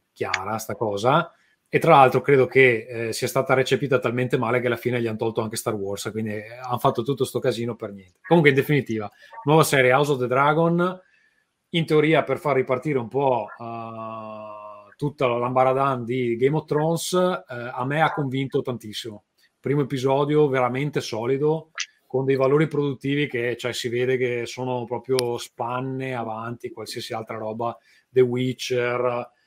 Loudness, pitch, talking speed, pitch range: -23 LUFS, 130 Hz, 170 wpm, 115-140 Hz